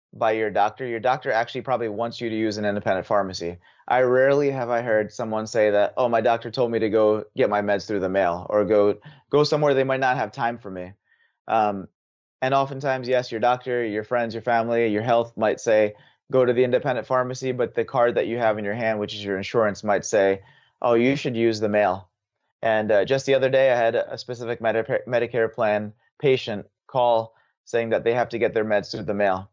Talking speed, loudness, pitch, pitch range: 225 wpm, -23 LUFS, 115 Hz, 105-125 Hz